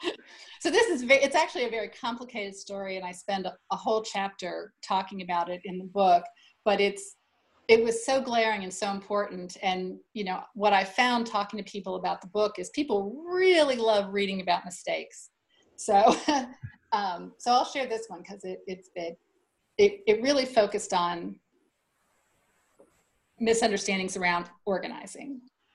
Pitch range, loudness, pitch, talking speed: 190-250 Hz, -27 LUFS, 205 Hz, 155 wpm